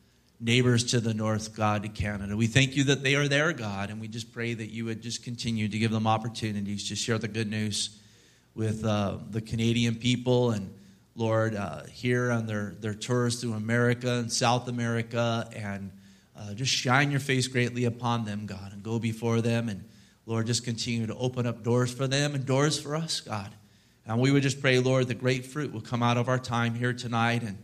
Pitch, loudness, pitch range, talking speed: 115 Hz, -28 LUFS, 110-125 Hz, 215 wpm